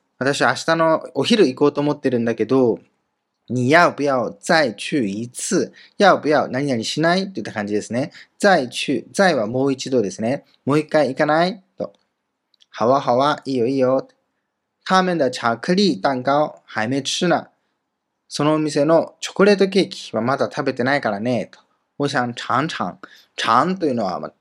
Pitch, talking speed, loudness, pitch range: 145 Hz, 350 characters per minute, -19 LUFS, 125-165 Hz